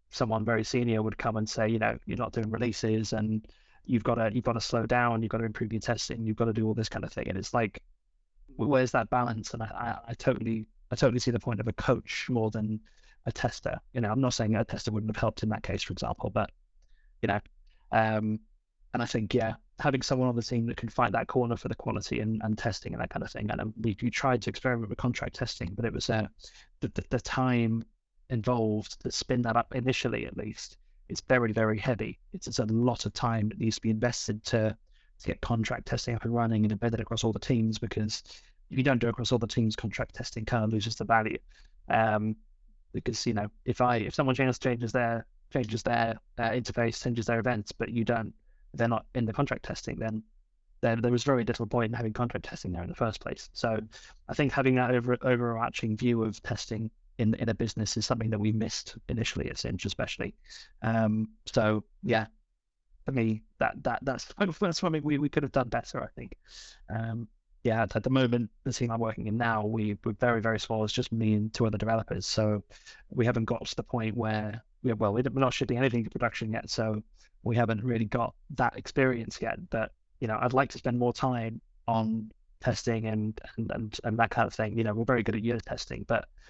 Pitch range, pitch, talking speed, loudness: 110-125 Hz, 115 Hz, 230 wpm, -30 LUFS